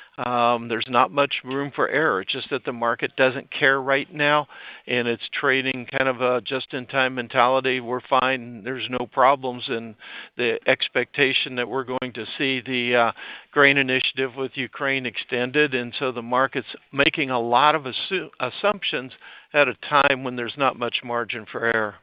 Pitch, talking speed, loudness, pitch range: 130 Hz, 175 wpm, -22 LUFS, 120-135 Hz